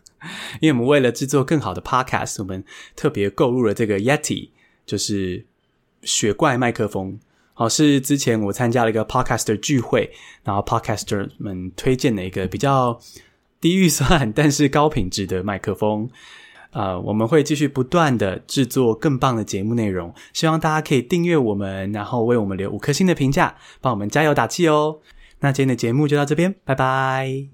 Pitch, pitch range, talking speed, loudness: 125 Hz, 105-145 Hz, 330 characters per minute, -20 LUFS